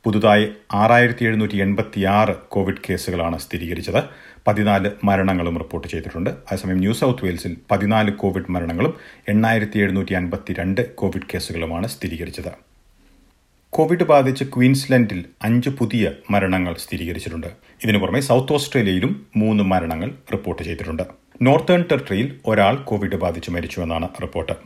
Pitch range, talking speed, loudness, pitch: 90-110 Hz, 110 wpm, -20 LUFS, 100 Hz